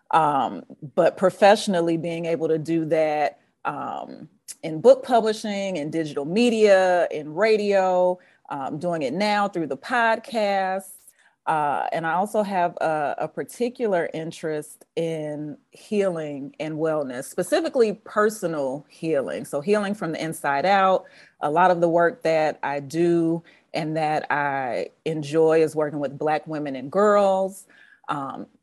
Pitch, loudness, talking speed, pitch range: 170 Hz, -23 LUFS, 140 wpm, 155-200 Hz